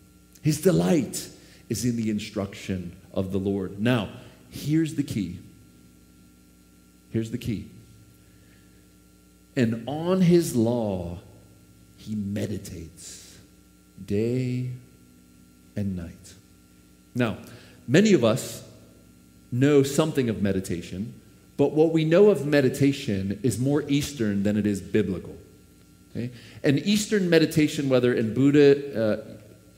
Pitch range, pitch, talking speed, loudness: 85-135 Hz, 105 Hz, 110 wpm, -24 LUFS